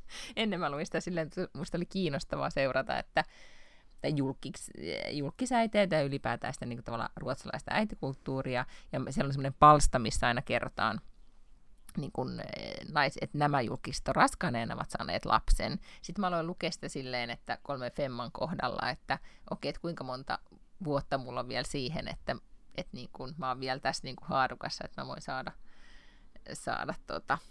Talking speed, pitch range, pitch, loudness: 165 wpm, 130-170 Hz, 145 Hz, -33 LUFS